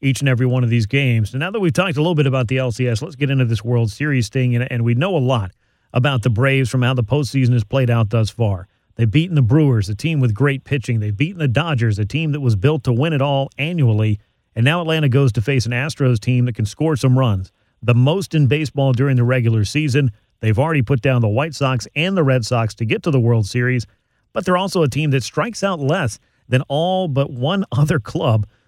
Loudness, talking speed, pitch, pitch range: -18 LUFS, 250 wpm, 130 Hz, 120-145 Hz